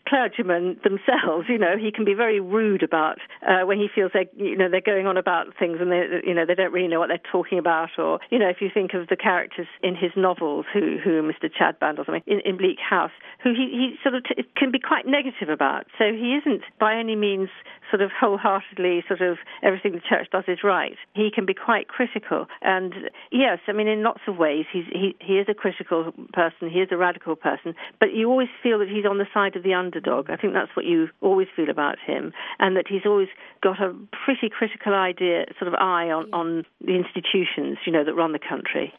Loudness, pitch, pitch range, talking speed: -23 LUFS, 195 Hz, 180-215 Hz, 235 wpm